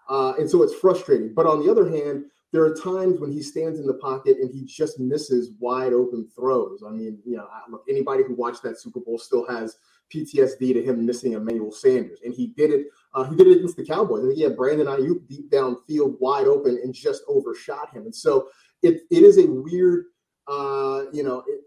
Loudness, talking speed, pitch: -21 LUFS, 225 wpm, 150 Hz